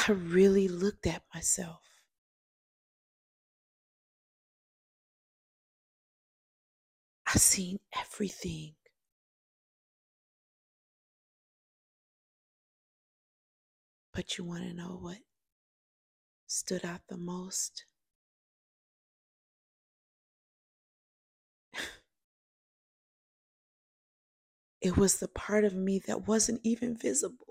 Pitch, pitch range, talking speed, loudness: 195 Hz, 180-210 Hz, 60 wpm, -31 LUFS